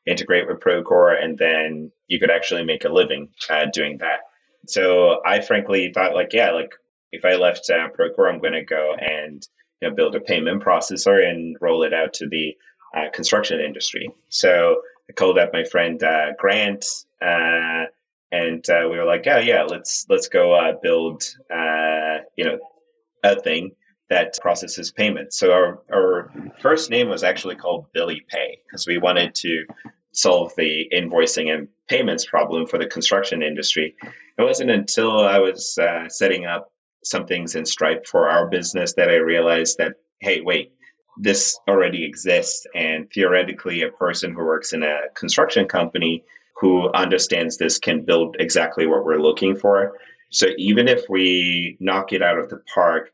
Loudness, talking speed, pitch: -19 LUFS, 170 wpm, 110 Hz